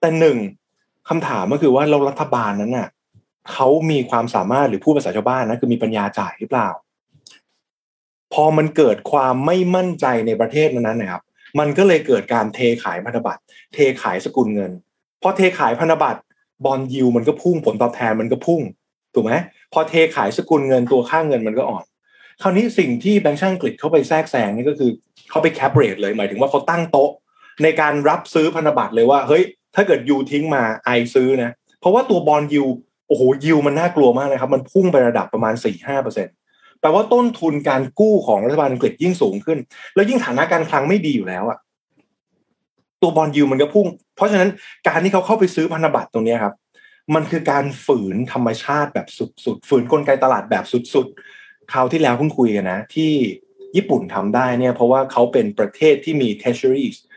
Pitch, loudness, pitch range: 150 Hz, -17 LUFS, 130-180 Hz